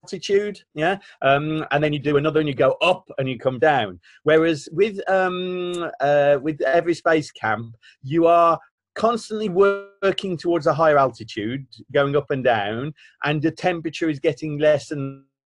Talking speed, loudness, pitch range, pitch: 165 wpm, -21 LUFS, 140-180 Hz, 155 Hz